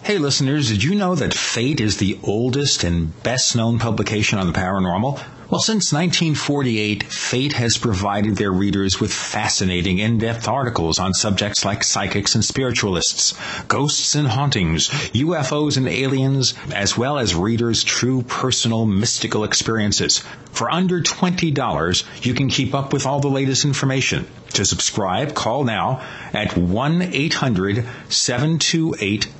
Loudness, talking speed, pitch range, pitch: -19 LUFS, 135 wpm, 105-140 Hz, 120 Hz